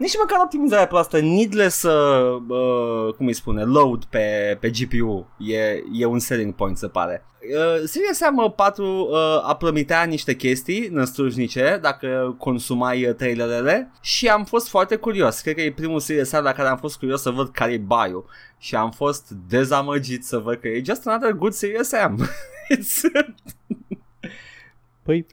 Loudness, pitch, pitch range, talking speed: -21 LUFS, 140 Hz, 120-200 Hz, 165 wpm